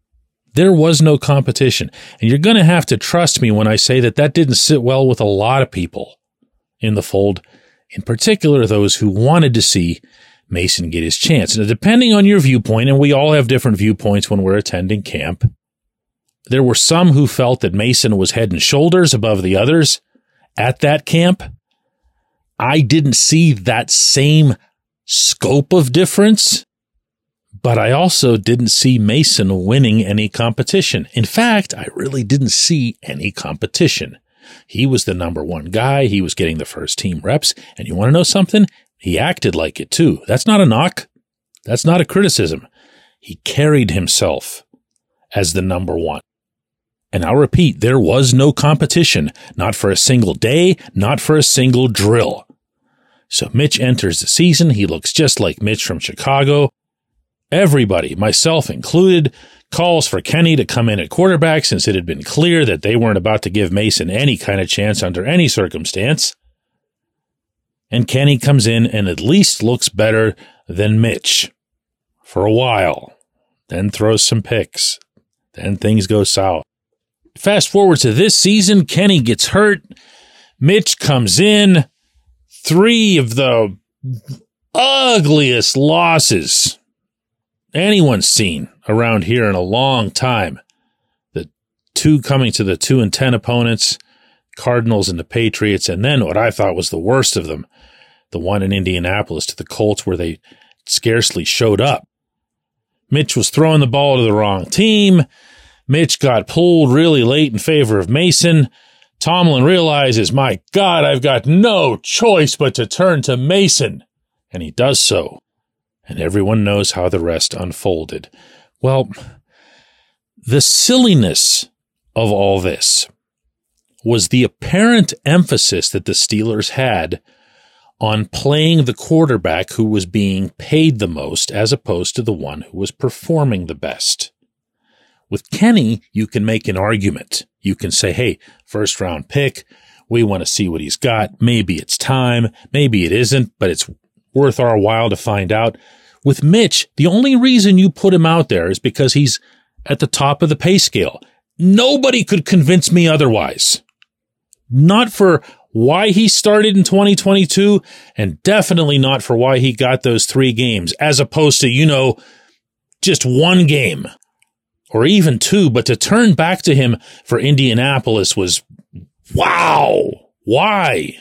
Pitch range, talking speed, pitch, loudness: 105-160 Hz, 160 wpm, 130 Hz, -13 LUFS